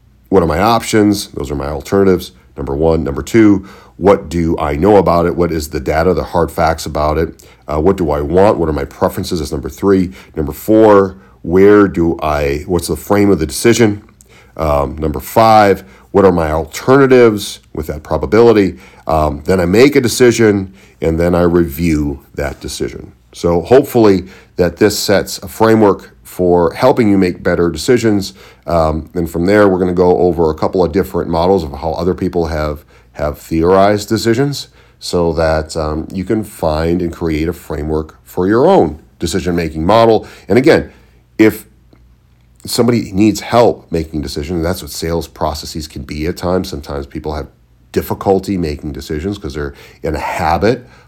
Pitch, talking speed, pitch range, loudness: 85 Hz, 175 wpm, 75-100 Hz, -13 LUFS